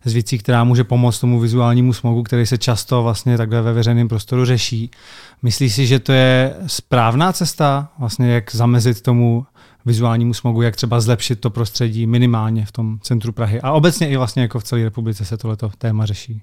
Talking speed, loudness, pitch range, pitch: 190 wpm, -16 LUFS, 115-125 Hz, 120 Hz